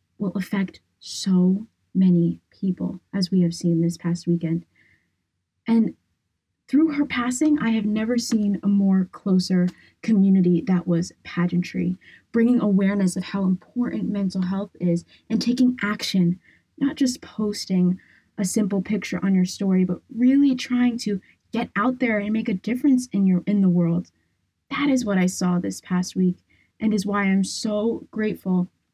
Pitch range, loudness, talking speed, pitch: 180-225 Hz, -23 LUFS, 160 wpm, 195 Hz